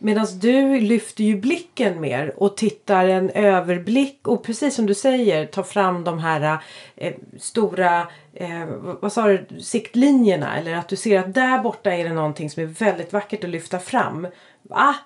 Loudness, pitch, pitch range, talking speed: -20 LUFS, 200 Hz, 175-230 Hz, 175 wpm